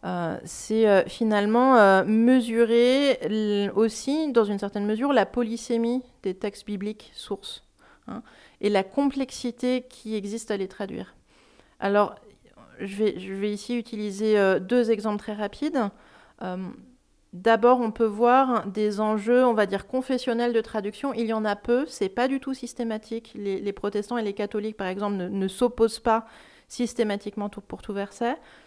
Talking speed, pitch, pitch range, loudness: 150 wpm, 220 Hz, 205-240 Hz, -25 LUFS